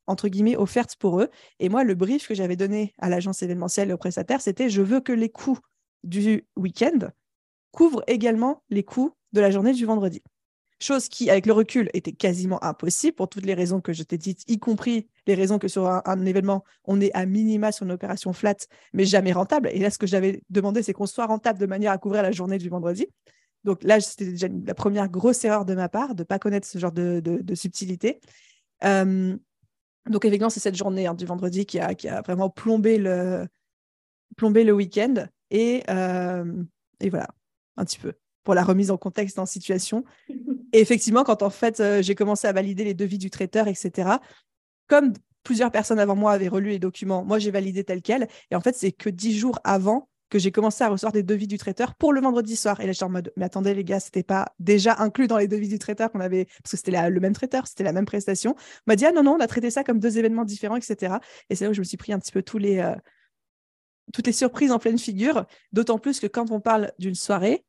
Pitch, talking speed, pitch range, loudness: 205 Hz, 240 wpm, 190-225 Hz, -23 LUFS